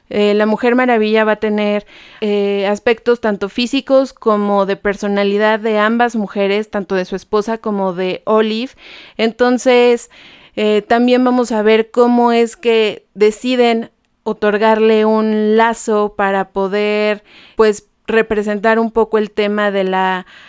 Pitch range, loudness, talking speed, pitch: 205-230 Hz, -14 LUFS, 140 wpm, 215 Hz